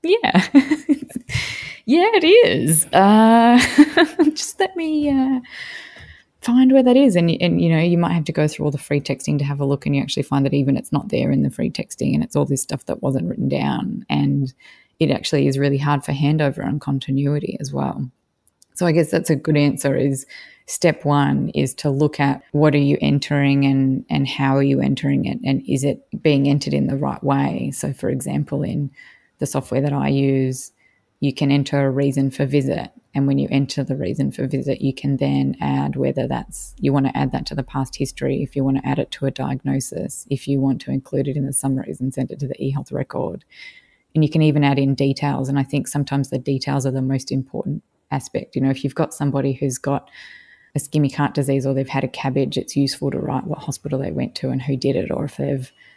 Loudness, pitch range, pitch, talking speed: -19 LUFS, 135-155 Hz, 140 Hz, 230 wpm